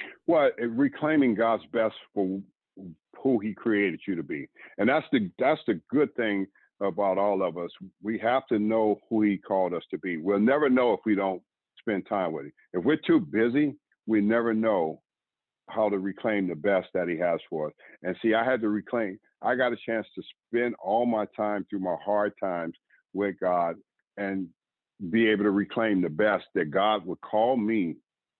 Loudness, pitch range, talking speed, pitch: -27 LUFS, 100-115 Hz, 195 wpm, 105 Hz